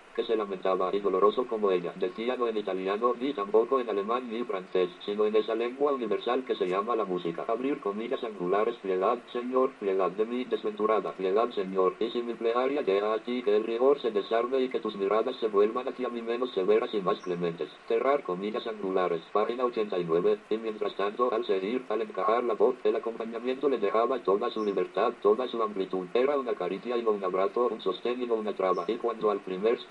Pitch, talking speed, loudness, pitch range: 115 Hz, 210 wpm, -29 LUFS, 105-135 Hz